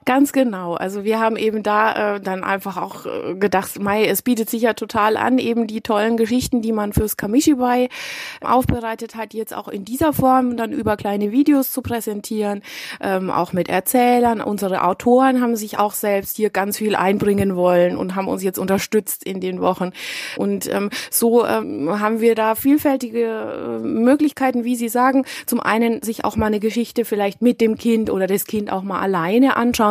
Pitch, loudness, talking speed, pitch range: 220 Hz, -19 LUFS, 185 wpm, 200-245 Hz